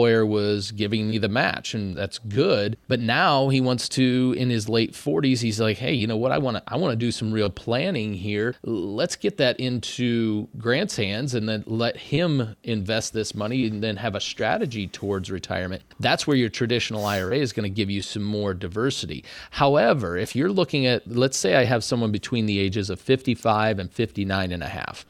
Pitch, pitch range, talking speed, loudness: 110 Hz, 105-125 Hz, 210 wpm, -24 LUFS